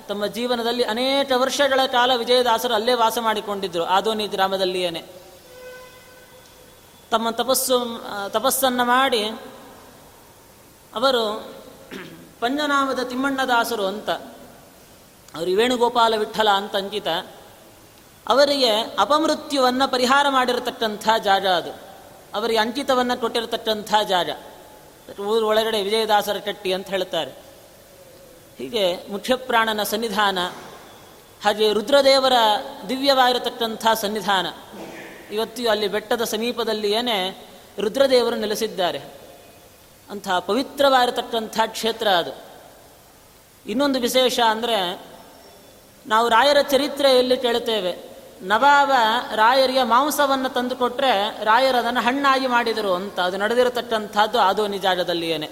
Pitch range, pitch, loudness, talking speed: 205-255 Hz, 230 Hz, -20 LUFS, 80 wpm